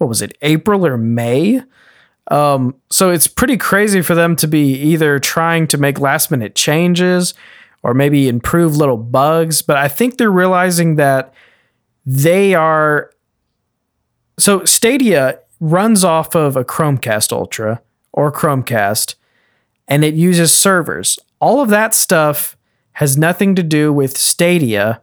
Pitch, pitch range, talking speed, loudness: 155 Hz, 135-180 Hz, 140 wpm, -13 LUFS